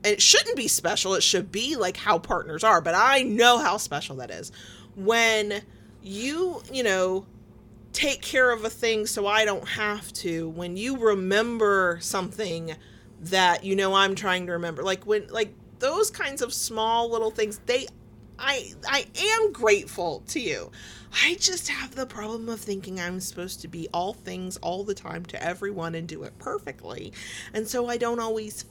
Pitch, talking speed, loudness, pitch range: 210 Hz, 180 wpm, -25 LUFS, 190-235 Hz